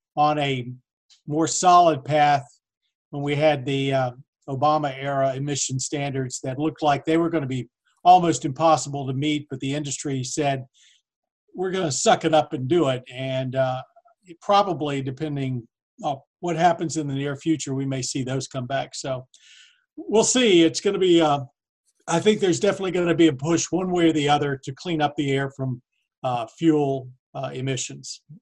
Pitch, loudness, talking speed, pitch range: 145 Hz, -23 LUFS, 190 wpm, 135-165 Hz